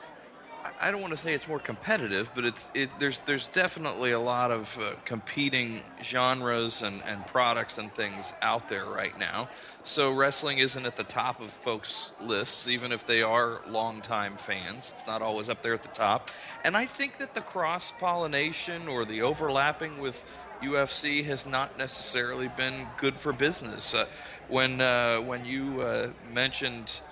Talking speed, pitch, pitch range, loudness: 175 wpm, 130 Hz, 120-145 Hz, -29 LUFS